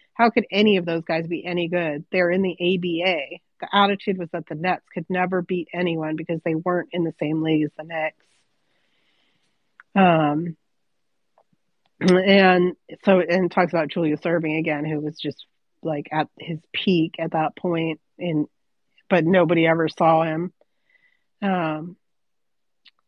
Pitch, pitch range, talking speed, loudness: 170 Hz, 160-180 Hz, 155 wpm, -22 LUFS